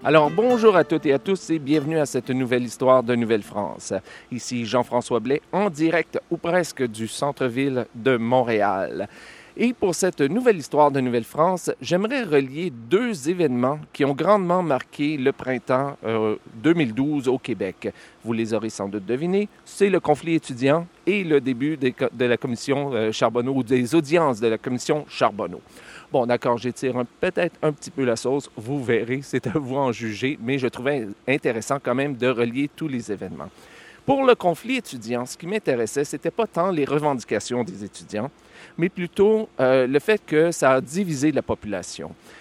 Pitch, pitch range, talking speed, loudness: 140 Hz, 125-165 Hz, 180 wpm, -23 LUFS